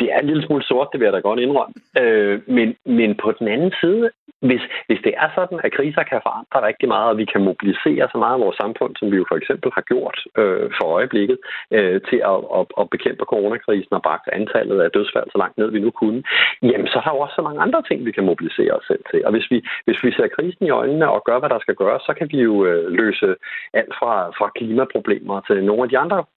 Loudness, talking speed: -19 LUFS, 255 wpm